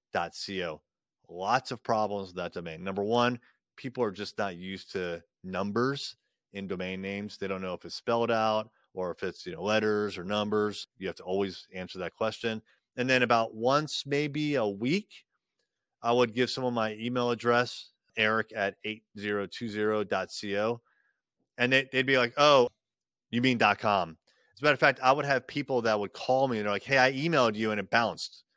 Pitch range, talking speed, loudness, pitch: 100-125 Hz, 190 wpm, -29 LUFS, 110 Hz